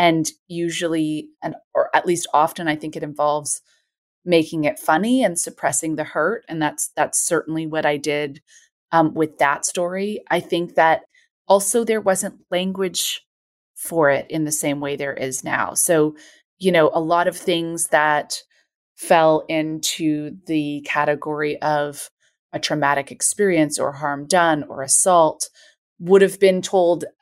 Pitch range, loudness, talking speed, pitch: 150-180 Hz, -20 LUFS, 155 wpm, 160 Hz